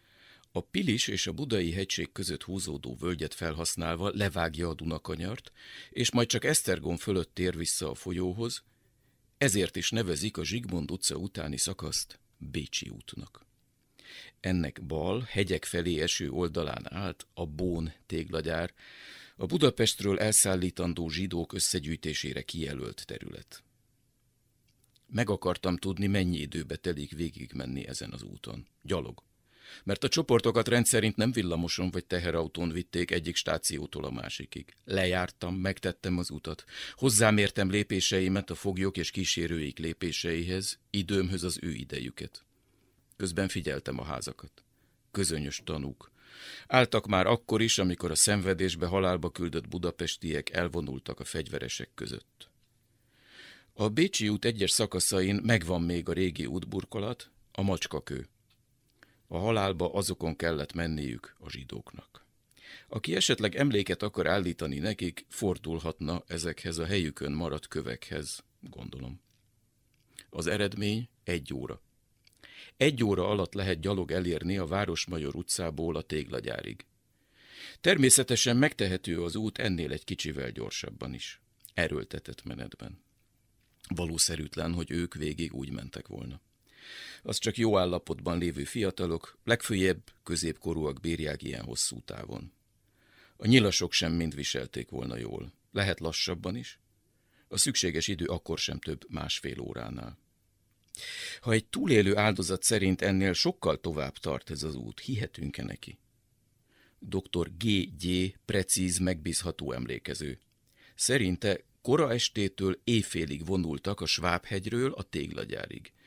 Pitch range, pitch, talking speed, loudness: 85-105 Hz, 90 Hz, 120 wpm, -31 LUFS